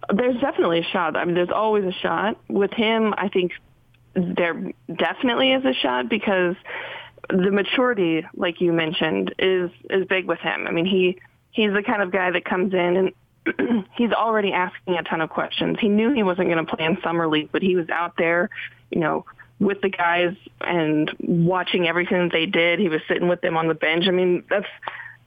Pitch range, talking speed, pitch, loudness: 170-205 Hz, 200 wpm, 180 Hz, -22 LUFS